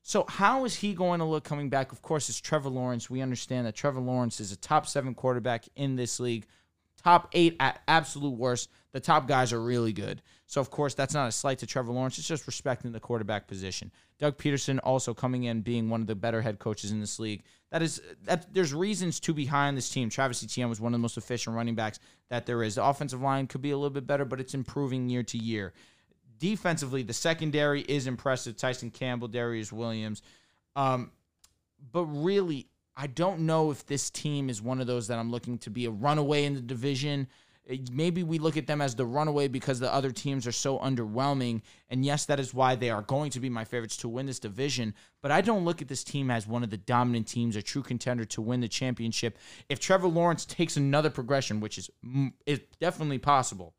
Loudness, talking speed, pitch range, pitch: -30 LUFS, 225 wpm, 115-145 Hz, 130 Hz